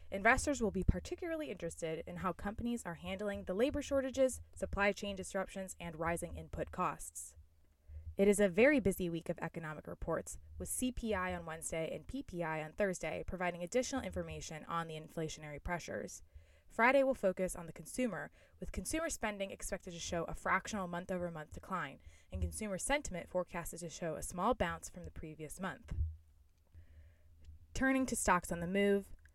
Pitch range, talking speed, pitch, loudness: 155-205 Hz, 165 wpm, 175 Hz, -38 LUFS